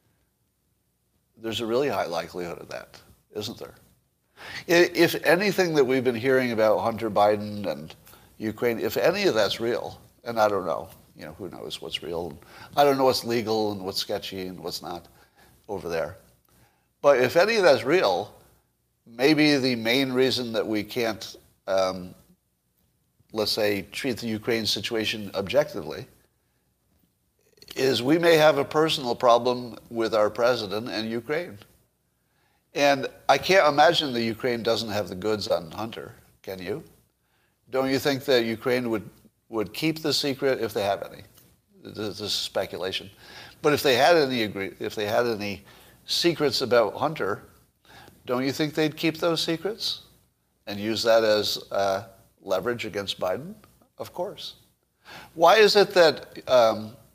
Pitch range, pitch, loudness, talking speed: 105-135 Hz, 115 Hz, -24 LUFS, 155 wpm